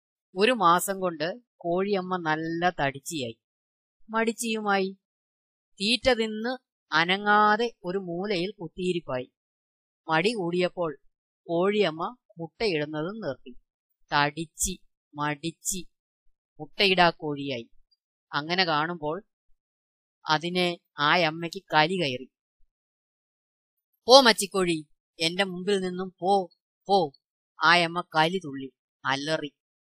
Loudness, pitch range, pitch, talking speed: -26 LUFS, 145-195 Hz, 170 Hz, 80 wpm